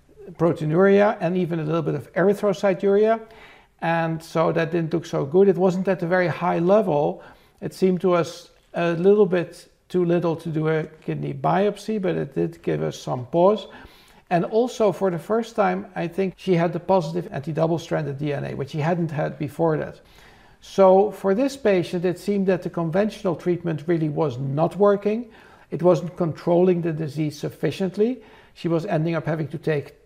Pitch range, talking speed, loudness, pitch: 165-195 Hz, 185 wpm, -22 LUFS, 175 Hz